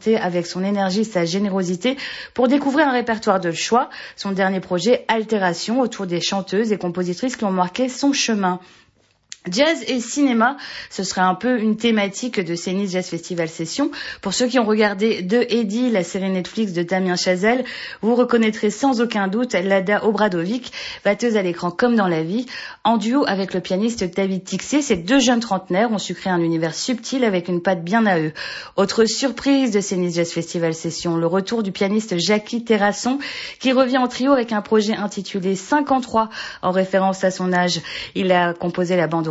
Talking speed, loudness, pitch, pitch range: 185 wpm, -20 LUFS, 200 Hz, 185-235 Hz